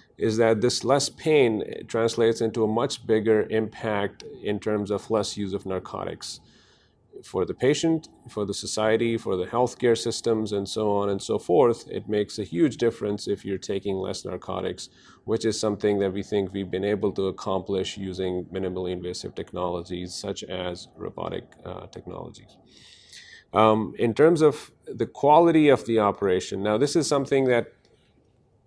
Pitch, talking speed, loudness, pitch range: 105 Hz, 165 wpm, -25 LUFS, 100-115 Hz